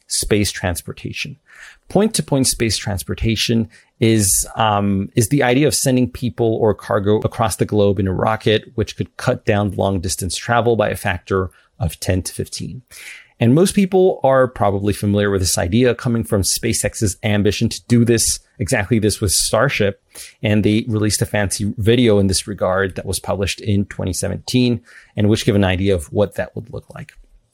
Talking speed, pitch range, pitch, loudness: 180 wpm, 100-120 Hz, 105 Hz, -17 LUFS